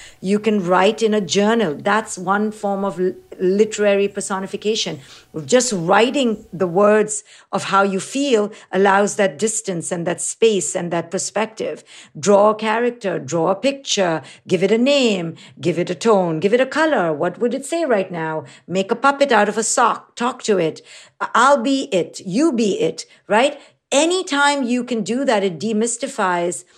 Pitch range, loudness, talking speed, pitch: 185-235 Hz, -18 LUFS, 175 wpm, 205 Hz